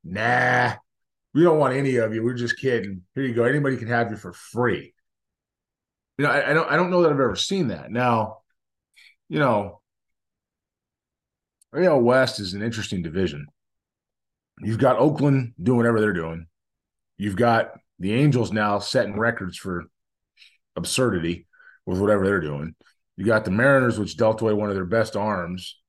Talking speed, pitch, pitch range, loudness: 170 wpm, 110 Hz, 95-125 Hz, -22 LUFS